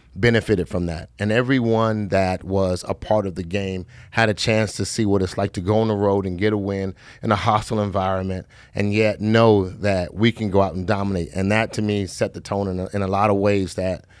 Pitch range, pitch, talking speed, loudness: 95-110 Hz, 100 Hz, 245 wpm, -21 LUFS